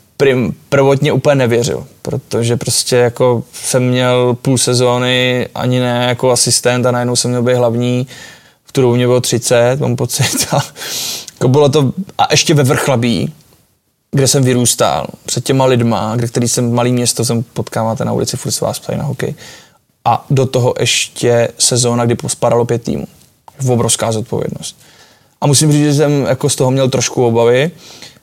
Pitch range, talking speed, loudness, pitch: 120-135 Hz, 170 wpm, -13 LUFS, 125 Hz